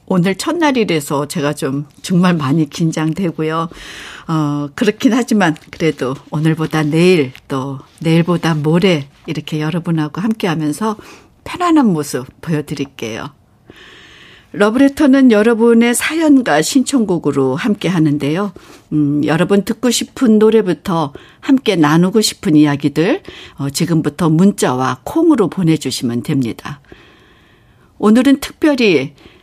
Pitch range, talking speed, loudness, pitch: 150-220 Hz, 280 characters per minute, -14 LUFS, 165 Hz